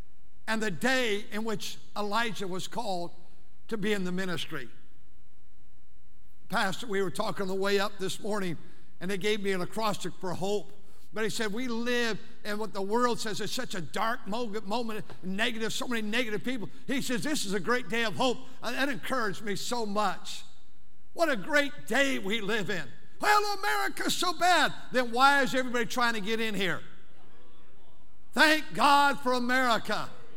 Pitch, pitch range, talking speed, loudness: 220 Hz, 200-250 Hz, 175 wpm, -30 LUFS